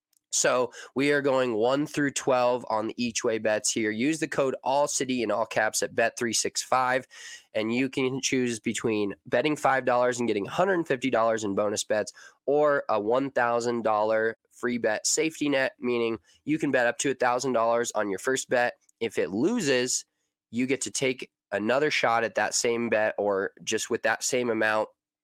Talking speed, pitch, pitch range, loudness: 170 wpm, 125 Hz, 110-135 Hz, -26 LUFS